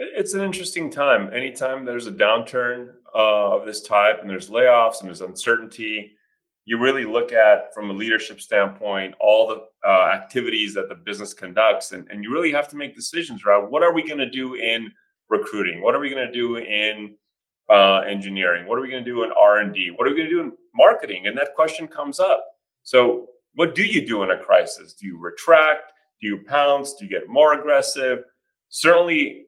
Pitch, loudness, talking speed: 130 Hz, -20 LUFS, 210 wpm